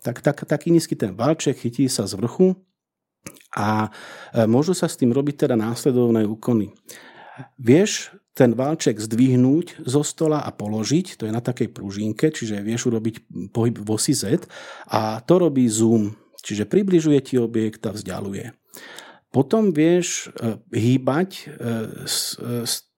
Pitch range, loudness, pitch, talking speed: 110-150 Hz, -21 LUFS, 125 Hz, 135 wpm